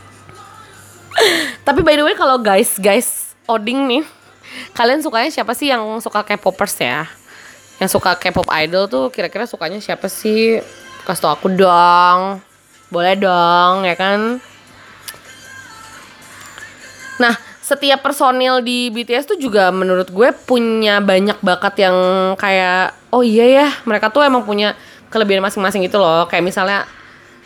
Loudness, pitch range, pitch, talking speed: -14 LUFS, 185-245 Hz, 205 Hz, 135 wpm